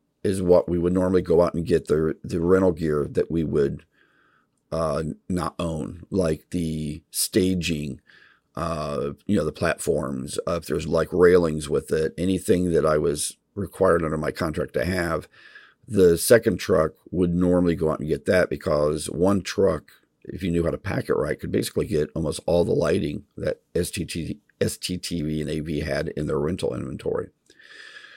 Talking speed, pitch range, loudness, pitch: 175 wpm, 80-90 Hz, -24 LUFS, 85 Hz